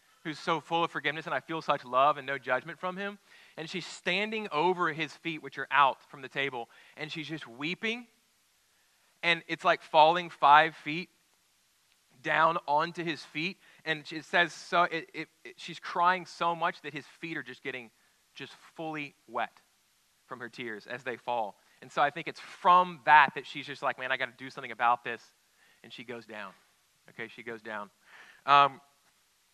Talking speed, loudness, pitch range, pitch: 195 wpm, -29 LUFS, 140-170 Hz, 155 Hz